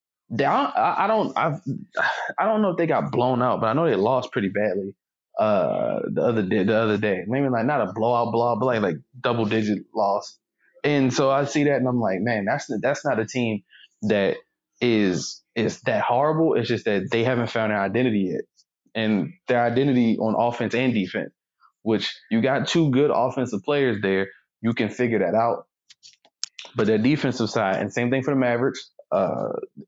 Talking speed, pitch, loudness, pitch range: 200 wpm, 120 Hz, -23 LUFS, 110-135 Hz